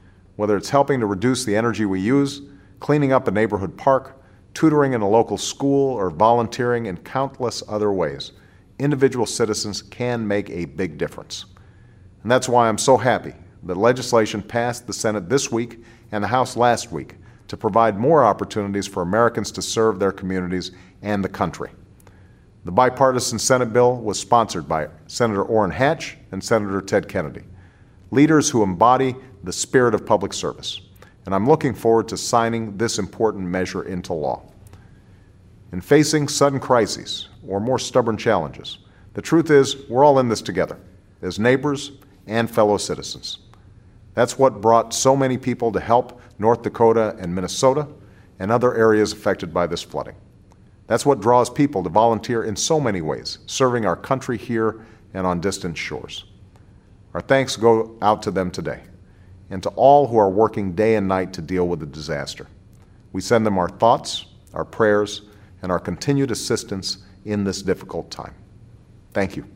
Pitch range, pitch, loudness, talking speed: 95-120 Hz, 105 Hz, -20 LUFS, 165 wpm